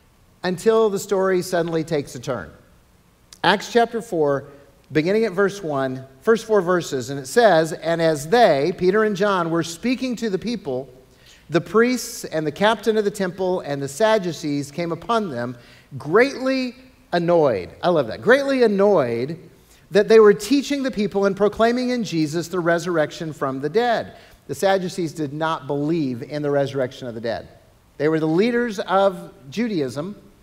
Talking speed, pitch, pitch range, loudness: 165 wpm, 175 Hz, 145-215 Hz, -21 LUFS